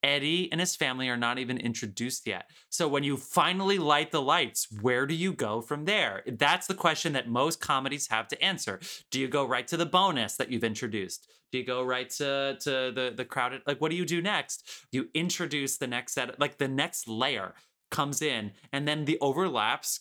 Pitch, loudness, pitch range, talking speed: 140 Hz, -29 LUFS, 125-160 Hz, 215 wpm